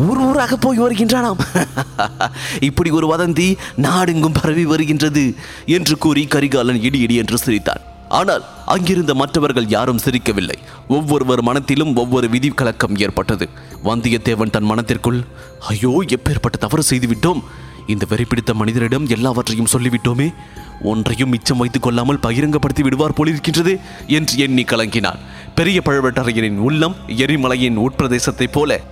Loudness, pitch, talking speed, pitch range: -16 LUFS, 130 Hz, 110 wpm, 120-150 Hz